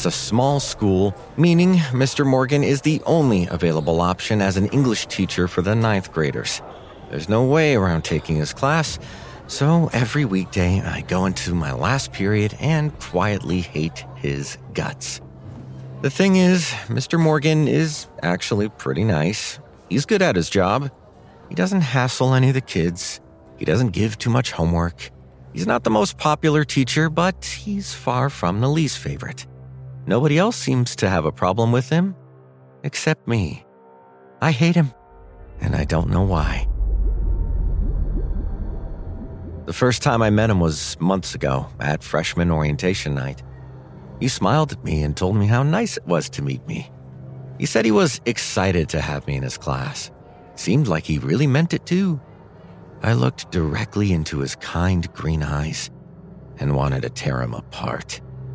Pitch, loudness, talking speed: 95 Hz, -21 LUFS, 165 wpm